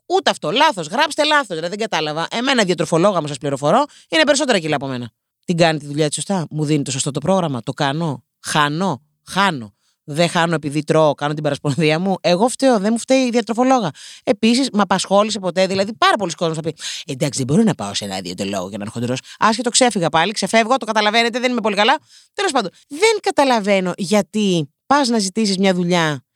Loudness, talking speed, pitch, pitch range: -18 LUFS, 205 wpm, 185 Hz, 150-230 Hz